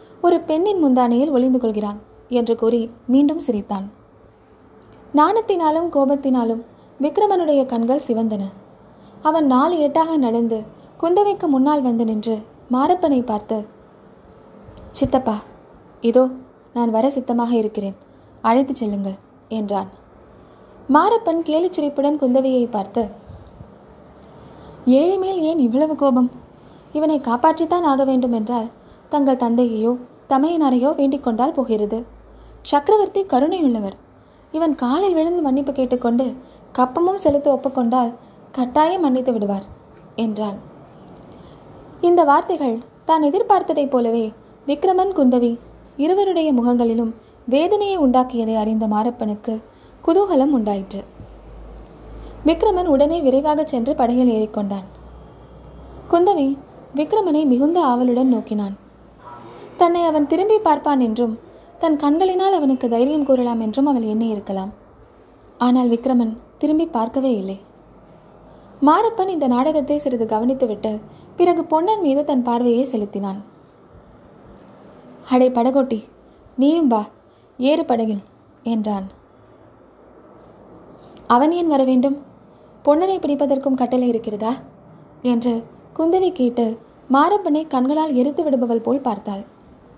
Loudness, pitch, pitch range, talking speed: -19 LUFS, 260 Hz, 230-305 Hz, 95 wpm